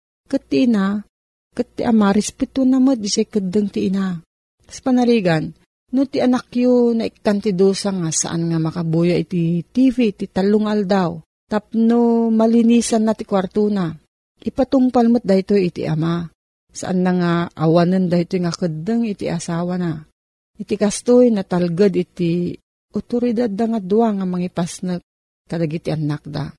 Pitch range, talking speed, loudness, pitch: 175-230 Hz, 140 wpm, -18 LUFS, 200 Hz